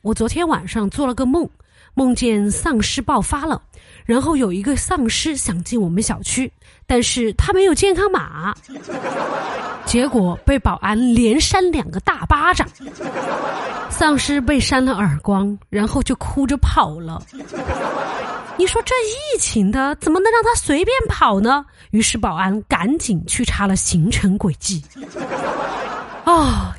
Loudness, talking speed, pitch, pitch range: -18 LUFS, 210 characters per minute, 250 Hz, 205-315 Hz